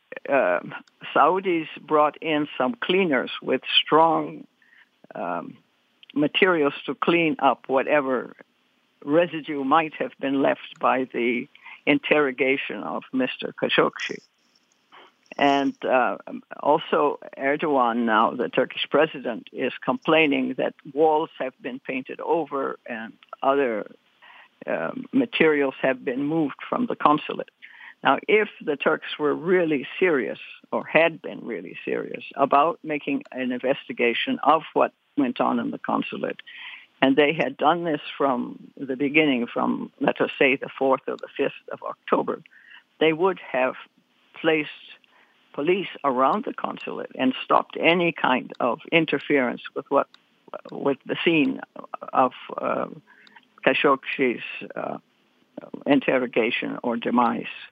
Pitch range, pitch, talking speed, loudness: 135-185 Hz, 150 Hz, 125 wpm, -23 LUFS